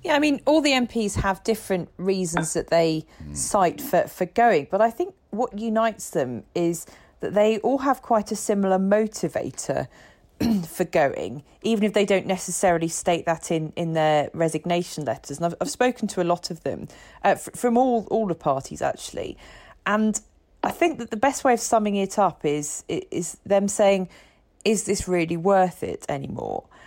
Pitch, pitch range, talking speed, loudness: 195 Hz, 170-225 Hz, 185 wpm, -24 LUFS